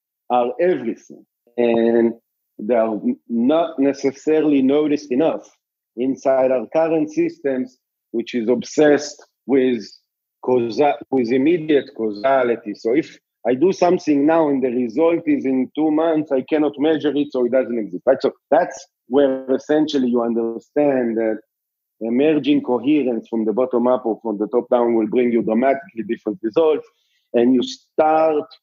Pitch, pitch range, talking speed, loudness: 130 Hz, 120-150 Hz, 150 wpm, -19 LUFS